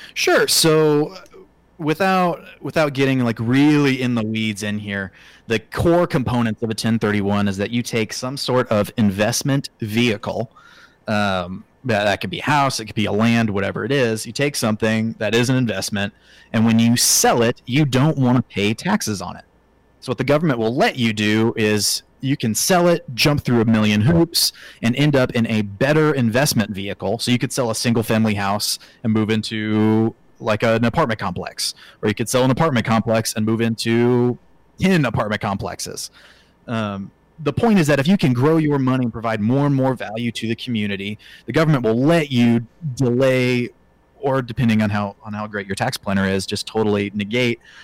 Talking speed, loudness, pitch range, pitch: 195 wpm, -19 LUFS, 105-135 Hz, 115 Hz